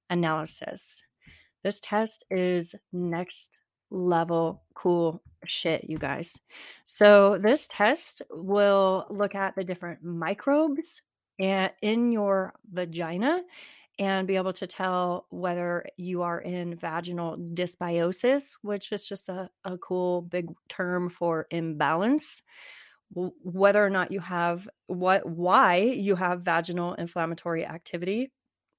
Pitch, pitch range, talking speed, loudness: 185 Hz, 175-205 Hz, 115 wpm, -27 LUFS